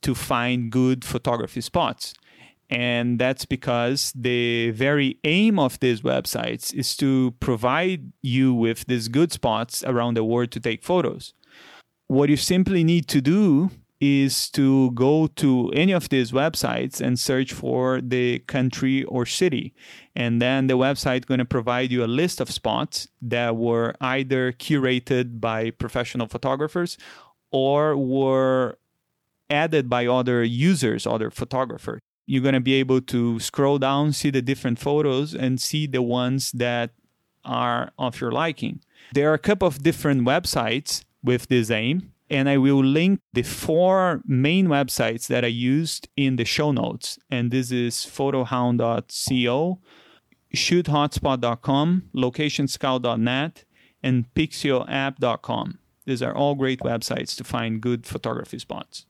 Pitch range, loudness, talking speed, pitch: 120-145 Hz, -22 LUFS, 140 wpm, 130 Hz